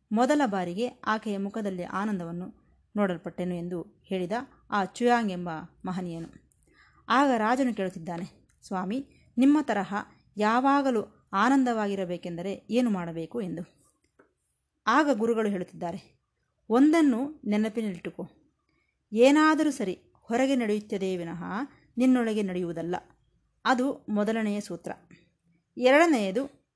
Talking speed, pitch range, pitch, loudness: 85 wpm, 180-250 Hz, 210 Hz, -27 LUFS